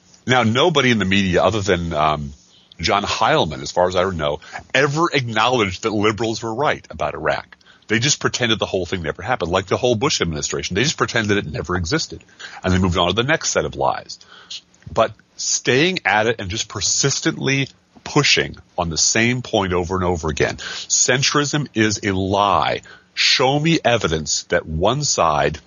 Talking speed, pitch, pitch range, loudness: 180 wpm, 105 Hz, 90-125 Hz, -18 LUFS